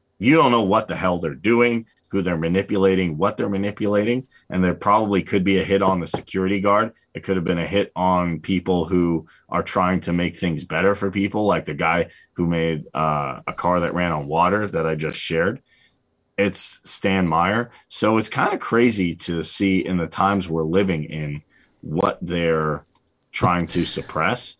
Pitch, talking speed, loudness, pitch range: 90 Hz, 195 wpm, -21 LUFS, 85-100 Hz